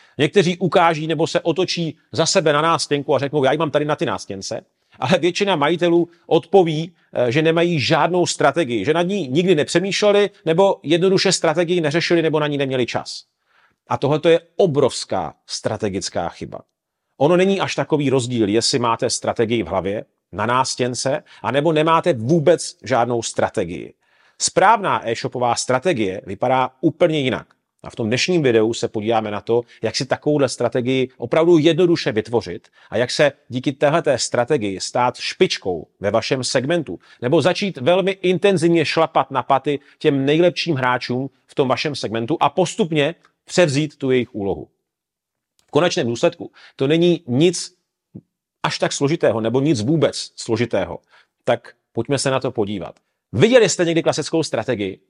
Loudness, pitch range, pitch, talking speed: -19 LUFS, 125-170 Hz, 150 Hz, 150 wpm